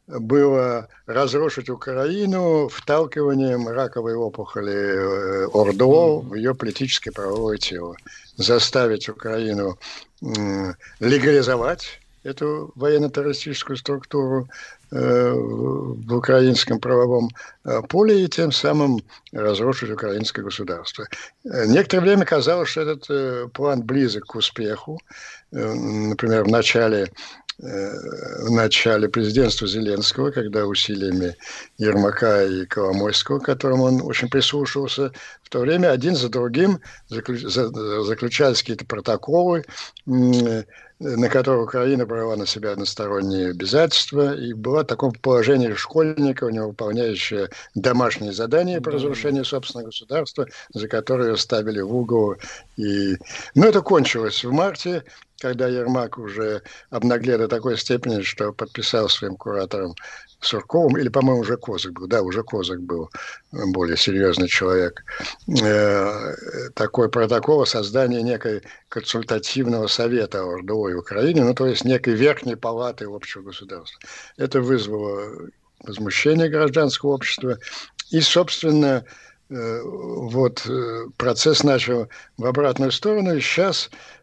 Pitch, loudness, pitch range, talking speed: 120 Hz, -21 LUFS, 105-140 Hz, 110 wpm